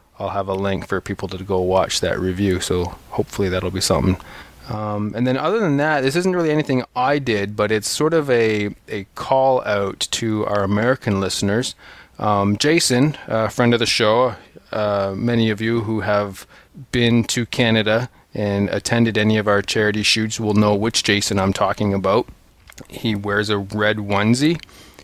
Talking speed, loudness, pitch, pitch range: 180 wpm, -19 LUFS, 105 Hz, 100-120 Hz